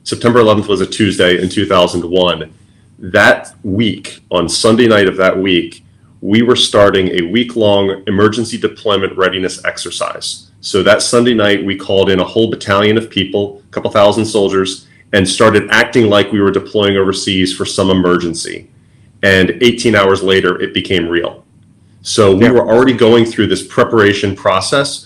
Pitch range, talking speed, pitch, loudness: 95-110 Hz, 165 wpm, 100 Hz, -12 LUFS